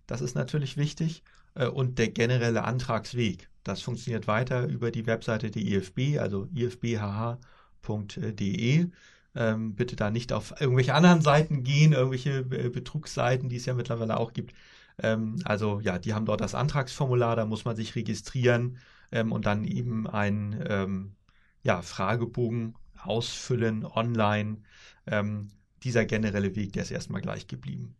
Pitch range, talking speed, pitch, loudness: 105-125 Hz, 135 wpm, 115 Hz, -28 LUFS